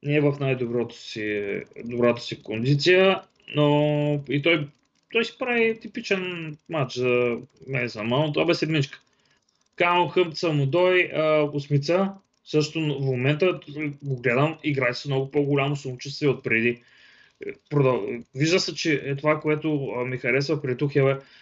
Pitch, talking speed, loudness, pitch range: 145 Hz, 135 wpm, -24 LUFS, 130-170 Hz